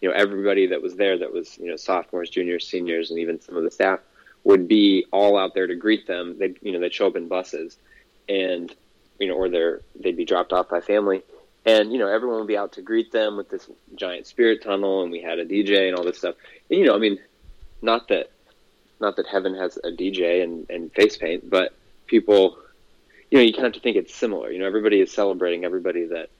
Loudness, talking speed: -22 LUFS, 240 wpm